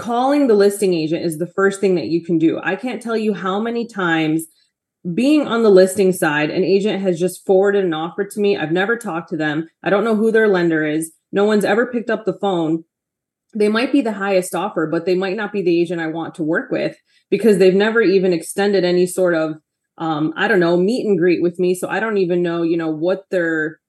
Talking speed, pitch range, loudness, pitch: 240 wpm, 170-200 Hz, -17 LUFS, 185 Hz